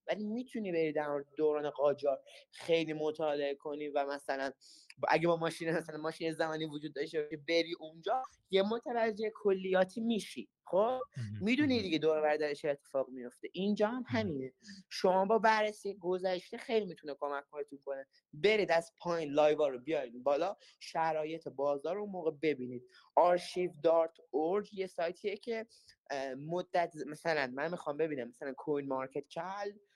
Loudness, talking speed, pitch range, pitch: -35 LUFS, 145 wpm, 145-195 Hz, 160 Hz